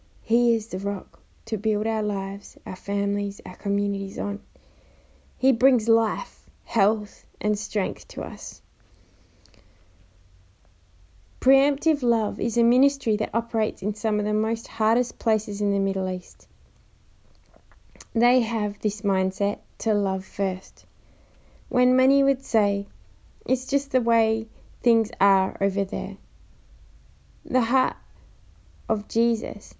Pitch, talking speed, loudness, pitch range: 210 Hz, 125 wpm, -24 LUFS, 190-230 Hz